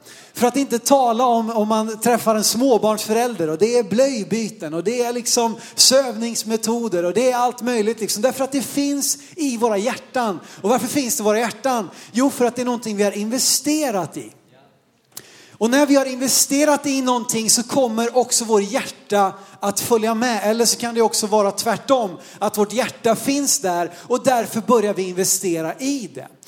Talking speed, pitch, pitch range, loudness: 190 wpm, 235 Hz, 210-255 Hz, -19 LUFS